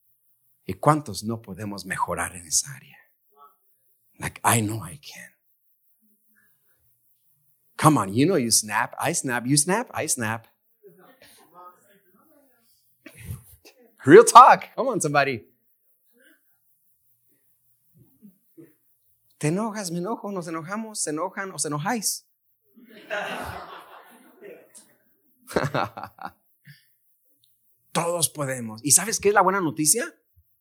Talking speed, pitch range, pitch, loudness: 100 wpm, 120-200 Hz, 150 Hz, -21 LUFS